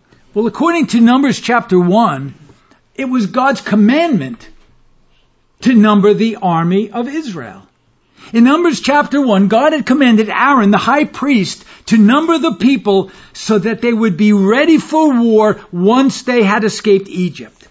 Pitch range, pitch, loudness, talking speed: 200-260 Hz, 225 Hz, -12 LUFS, 150 wpm